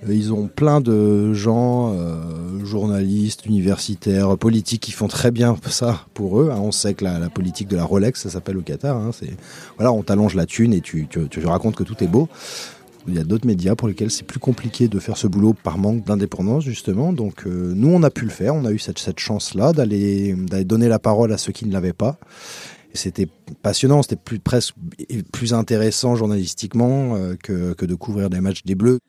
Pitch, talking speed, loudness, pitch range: 105 Hz, 225 wpm, -20 LUFS, 95-115 Hz